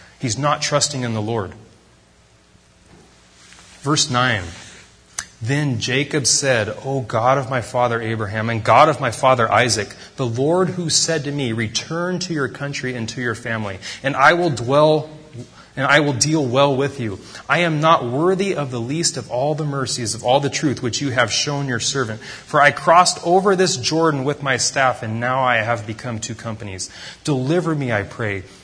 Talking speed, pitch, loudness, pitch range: 185 wpm, 130 Hz, -18 LUFS, 115-145 Hz